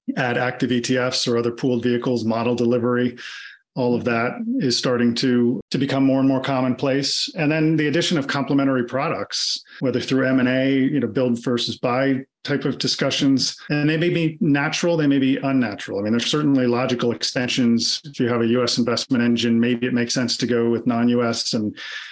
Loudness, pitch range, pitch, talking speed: -20 LUFS, 120-135 Hz, 125 Hz, 195 wpm